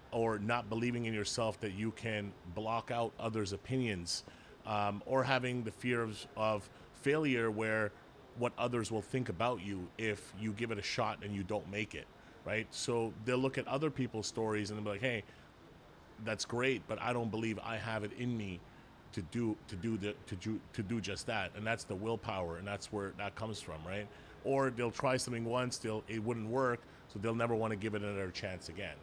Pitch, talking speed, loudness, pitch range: 110 Hz, 210 wpm, -38 LUFS, 105-120 Hz